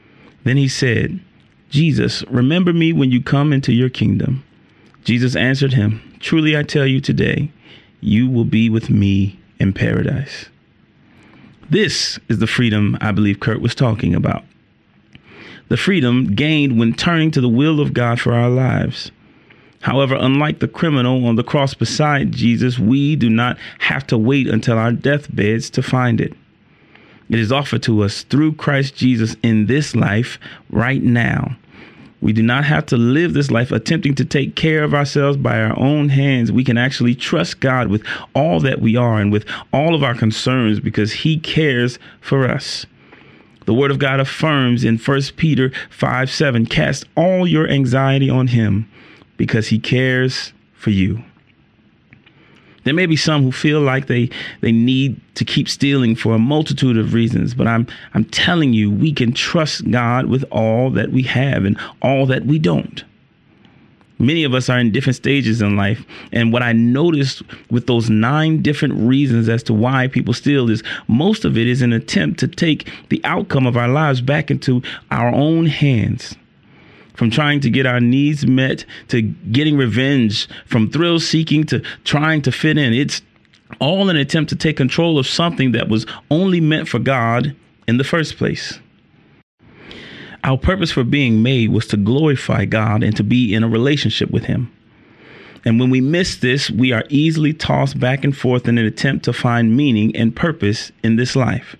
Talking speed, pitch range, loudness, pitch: 175 wpm, 115-145 Hz, -16 LUFS, 130 Hz